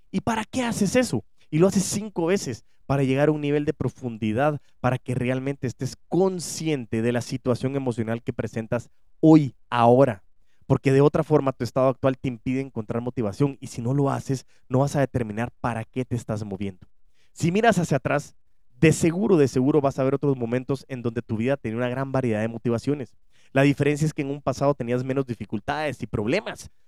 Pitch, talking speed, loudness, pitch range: 130 Hz, 200 wpm, -24 LUFS, 120-145 Hz